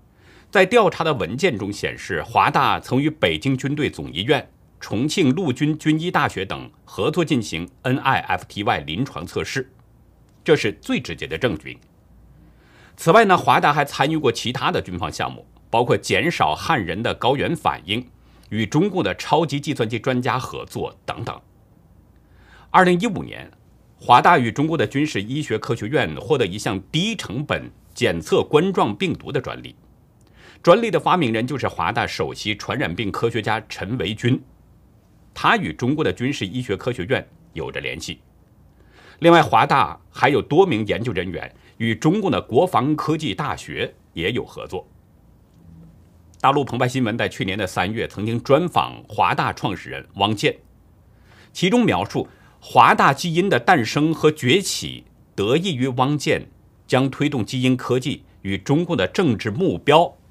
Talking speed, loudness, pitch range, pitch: 245 characters per minute, -20 LUFS, 105-145 Hz, 125 Hz